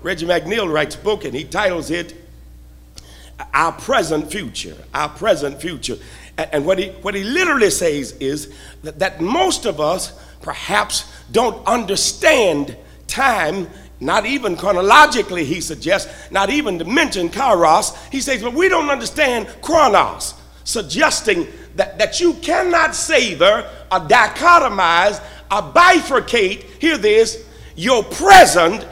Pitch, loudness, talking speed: 205 Hz, -16 LUFS, 135 wpm